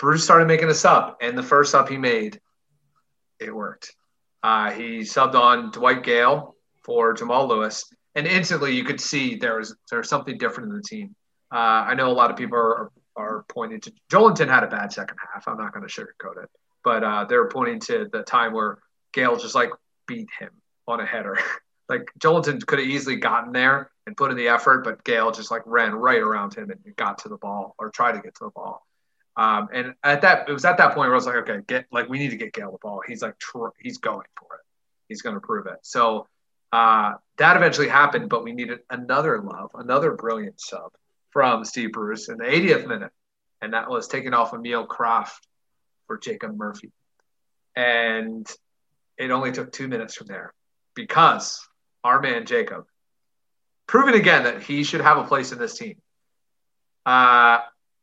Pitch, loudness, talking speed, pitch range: 140 Hz, -20 LUFS, 205 wpm, 120-200 Hz